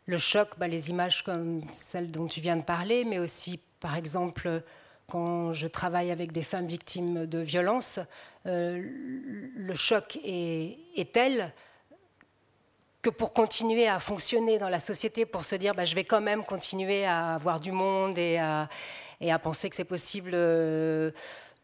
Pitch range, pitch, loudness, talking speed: 170-205 Hz, 180 Hz, -30 LUFS, 170 wpm